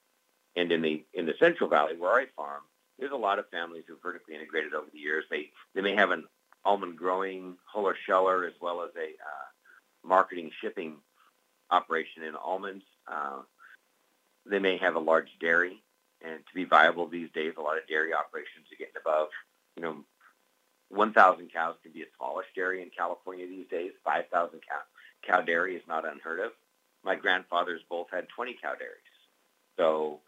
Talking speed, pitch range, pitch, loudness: 180 wpm, 80-95 Hz, 90 Hz, -30 LUFS